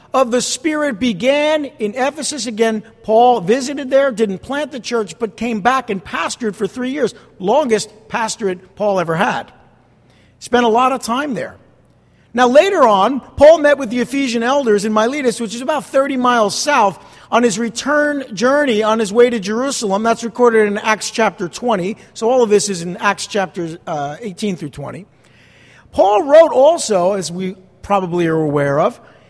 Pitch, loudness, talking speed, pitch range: 230 Hz, -15 LUFS, 175 wpm, 200-265 Hz